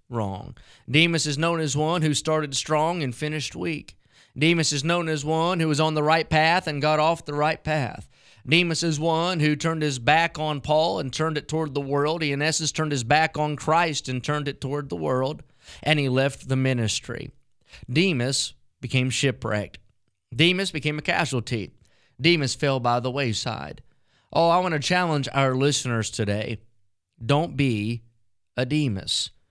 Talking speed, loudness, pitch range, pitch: 175 wpm, -23 LUFS, 125-155 Hz, 145 Hz